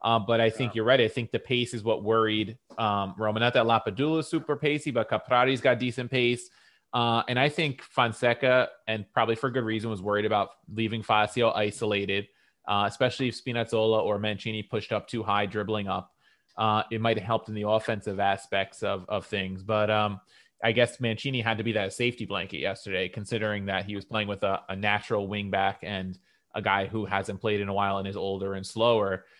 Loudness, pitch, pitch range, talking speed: -27 LUFS, 110 Hz, 100-120 Hz, 210 wpm